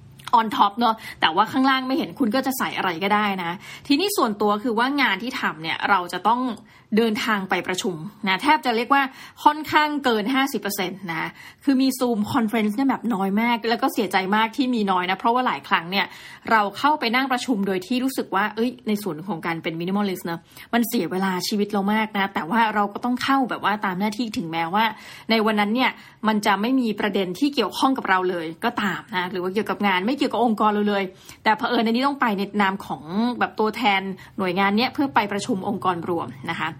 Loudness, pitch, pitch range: -22 LUFS, 220 Hz, 195-245 Hz